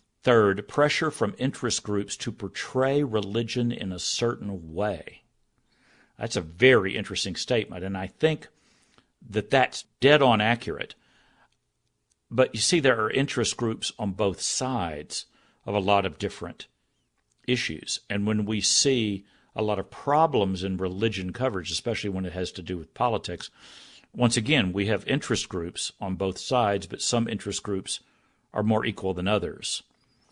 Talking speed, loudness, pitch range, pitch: 155 wpm, -26 LUFS, 95-120 Hz, 105 Hz